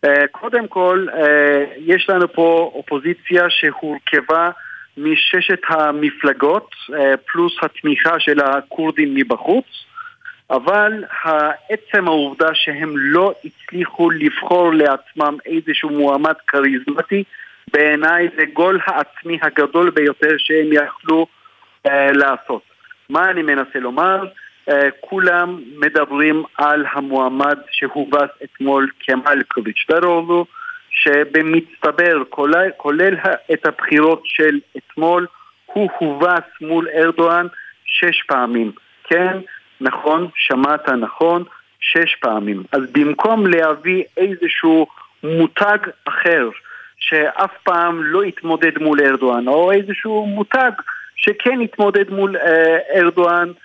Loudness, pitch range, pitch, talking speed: -16 LUFS, 150-190 Hz, 165 Hz, 95 wpm